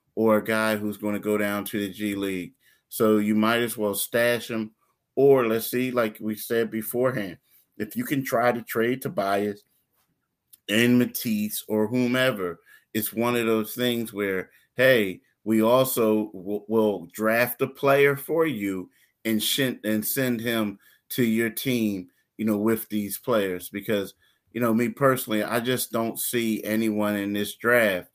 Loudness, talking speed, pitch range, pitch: -25 LUFS, 170 wpm, 105-120 Hz, 110 Hz